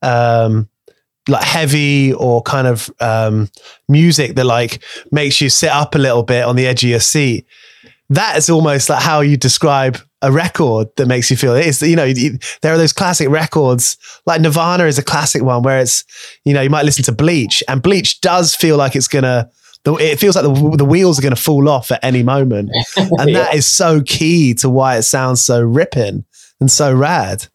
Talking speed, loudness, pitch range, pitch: 205 wpm, -12 LUFS, 125-155 Hz, 140 Hz